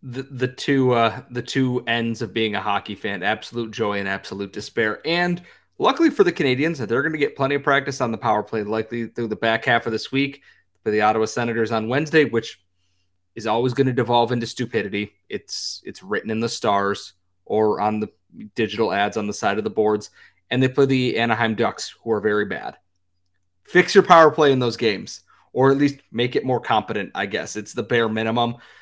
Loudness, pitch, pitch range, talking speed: -21 LUFS, 115 Hz, 105-135 Hz, 210 wpm